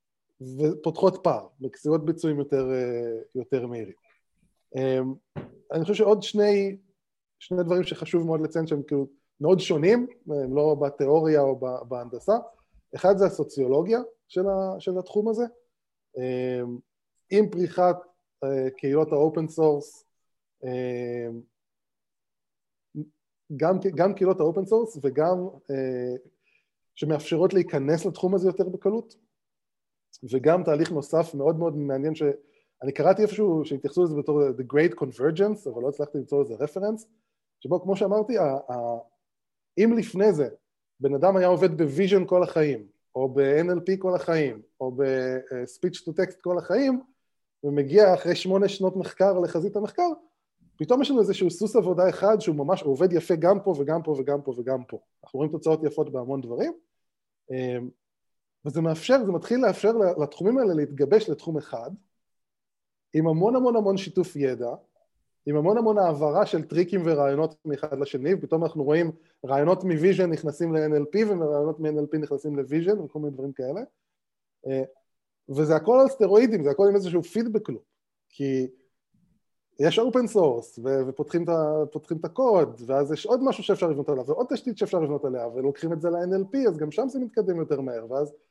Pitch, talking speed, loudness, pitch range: 160 Hz, 145 wpm, -25 LUFS, 140-195 Hz